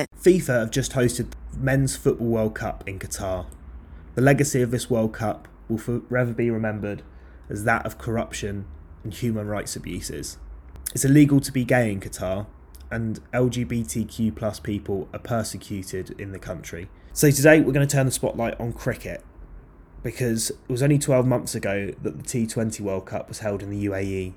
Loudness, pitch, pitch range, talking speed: -24 LUFS, 110 Hz, 95-125 Hz, 175 wpm